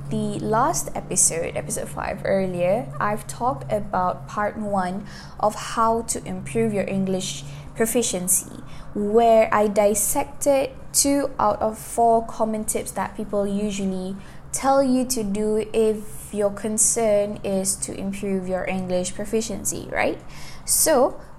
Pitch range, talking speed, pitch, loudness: 190-225 Hz, 125 wpm, 210 Hz, -22 LUFS